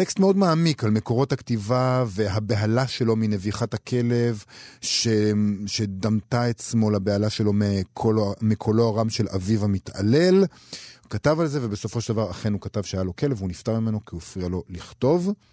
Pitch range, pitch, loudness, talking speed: 105-120 Hz, 110 Hz, -23 LUFS, 165 wpm